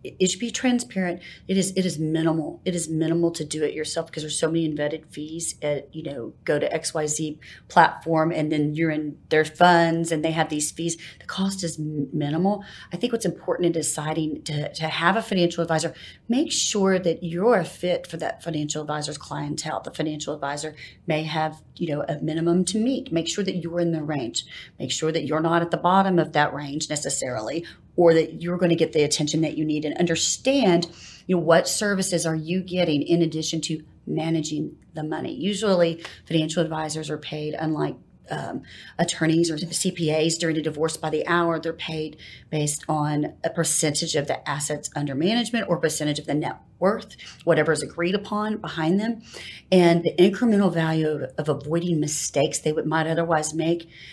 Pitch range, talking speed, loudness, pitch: 155-175 Hz, 195 wpm, -24 LUFS, 160 Hz